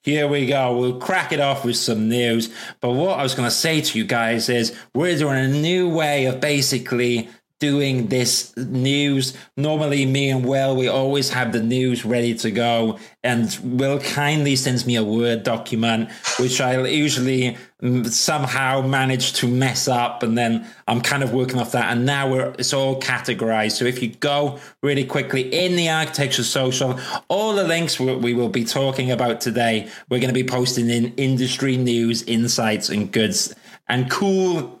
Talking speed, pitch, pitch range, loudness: 180 wpm, 130 Hz, 120-140 Hz, -20 LUFS